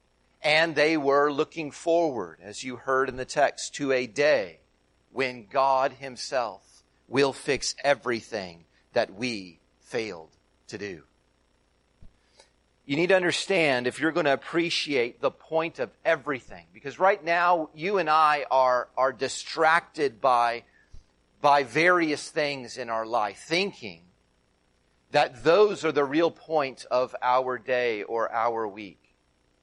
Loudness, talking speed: -25 LUFS, 135 wpm